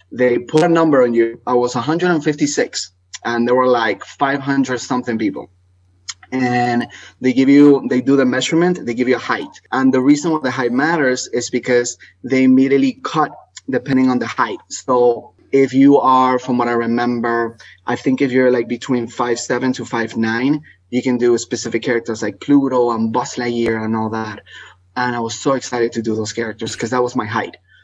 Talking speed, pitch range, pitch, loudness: 195 wpm, 115-130 Hz, 125 Hz, -17 LUFS